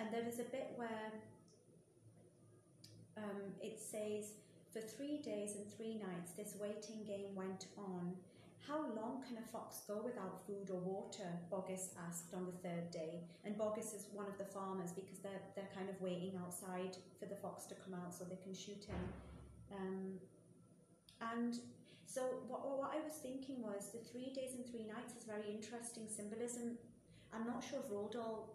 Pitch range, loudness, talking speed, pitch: 190-230 Hz, -48 LUFS, 180 wpm, 205 Hz